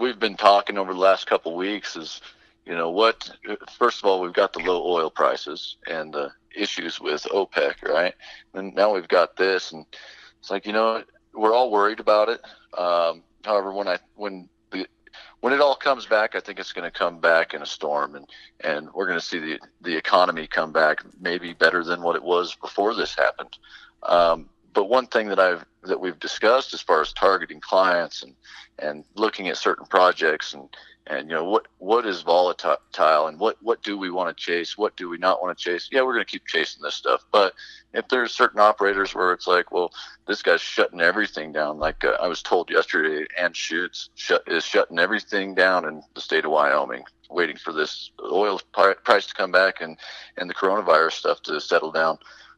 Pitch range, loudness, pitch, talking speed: 85-110 Hz, -22 LUFS, 95 Hz, 210 wpm